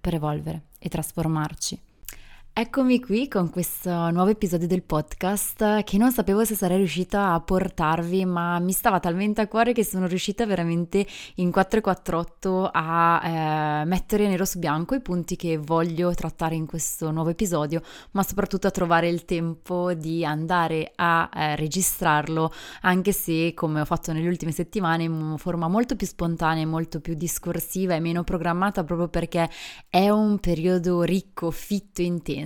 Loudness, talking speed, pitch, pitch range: -24 LUFS, 160 wpm, 175 Hz, 165-190 Hz